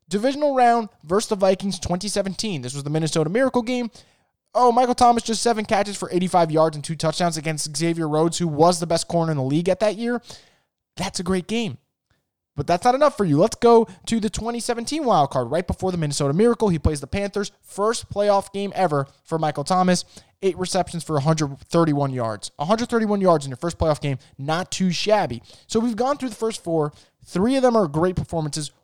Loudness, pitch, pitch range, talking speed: -22 LUFS, 185 Hz, 160-220 Hz, 205 wpm